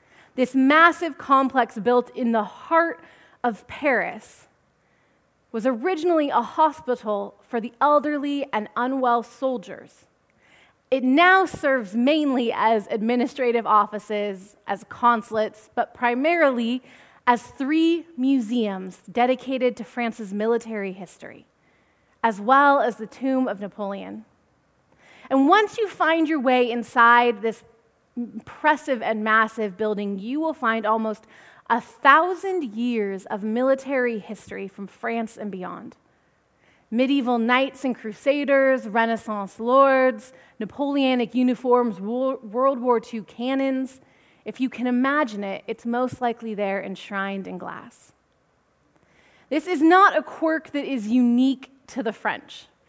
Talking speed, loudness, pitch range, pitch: 120 wpm, -22 LUFS, 220-270 Hz, 245 Hz